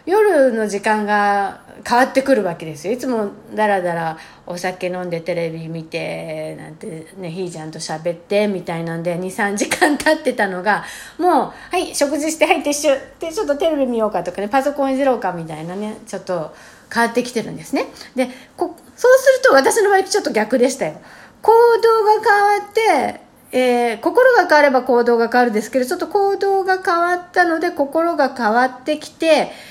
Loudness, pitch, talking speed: -17 LUFS, 250 Hz, 375 characters per minute